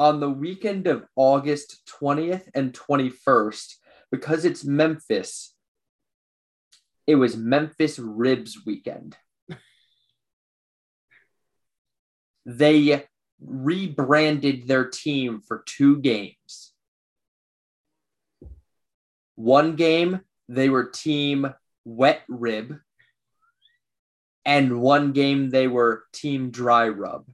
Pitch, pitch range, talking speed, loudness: 135 Hz, 120-150 Hz, 85 wpm, -22 LUFS